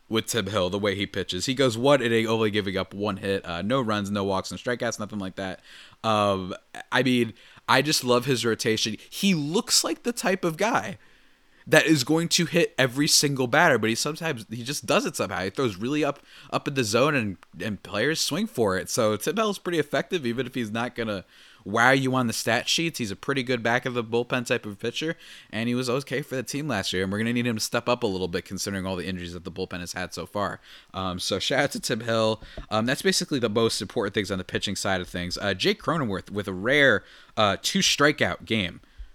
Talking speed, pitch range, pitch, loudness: 245 wpm, 100-135 Hz, 115 Hz, -25 LUFS